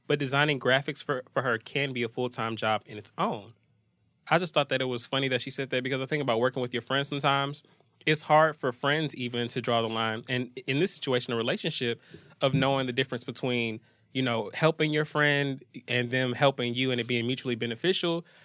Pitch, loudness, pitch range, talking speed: 130 Hz, -28 LUFS, 120-145 Hz, 220 wpm